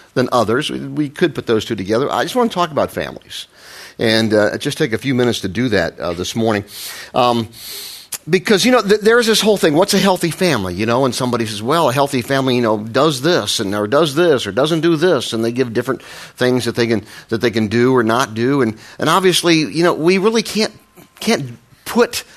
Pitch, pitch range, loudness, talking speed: 130 Hz, 115-175 Hz, -16 LUFS, 235 wpm